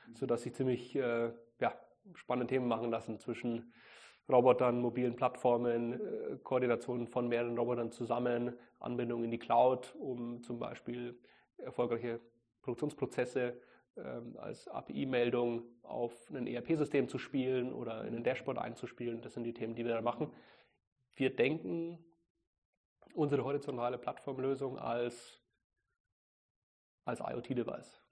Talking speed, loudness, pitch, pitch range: 120 wpm, -37 LUFS, 120 Hz, 120-125 Hz